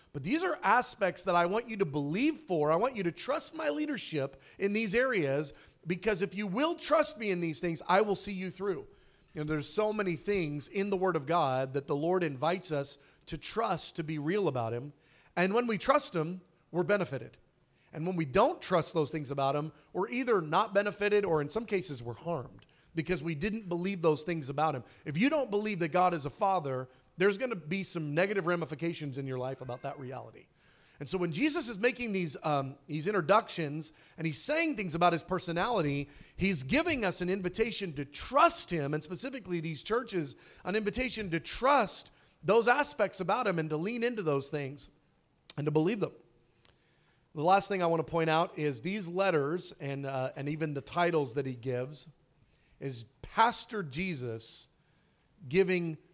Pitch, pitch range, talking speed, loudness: 175 Hz, 150-200 Hz, 200 wpm, -32 LUFS